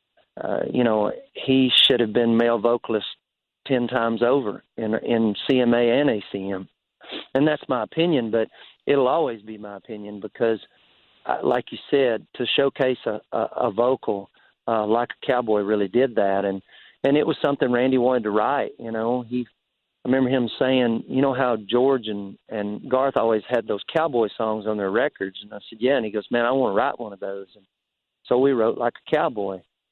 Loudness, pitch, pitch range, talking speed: -22 LUFS, 115 Hz, 105-130 Hz, 195 wpm